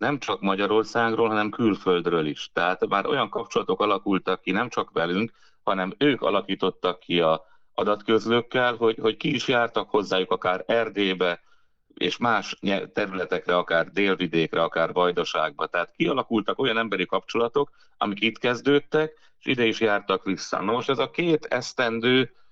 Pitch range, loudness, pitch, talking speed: 95-120 Hz, -24 LUFS, 110 Hz, 150 wpm